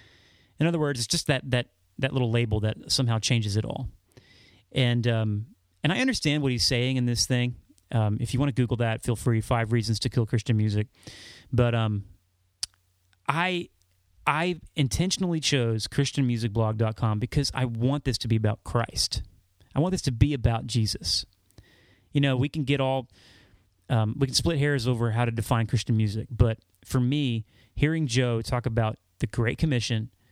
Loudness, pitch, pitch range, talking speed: -26 LUFS, 120 Hz, 105-130 Hz, 180 wpm